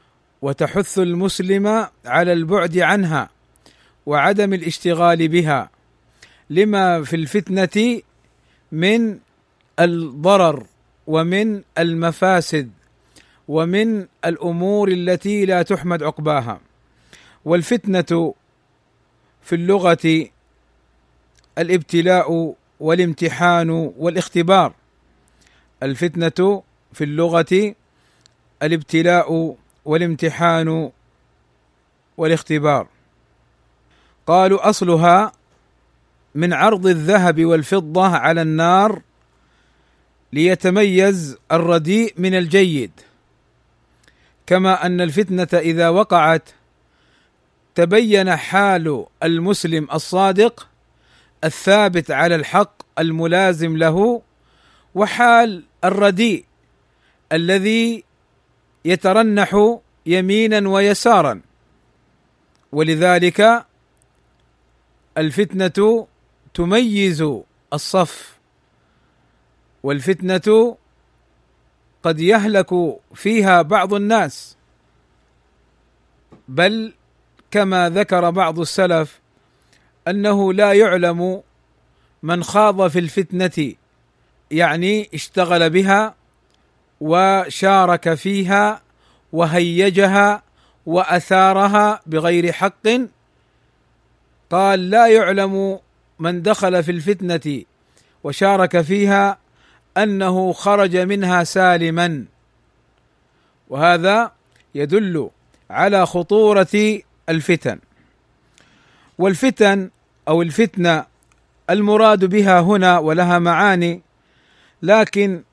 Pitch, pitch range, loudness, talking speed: 180 Hz, 160-195 Hz, -16 LUFS, 65 wpm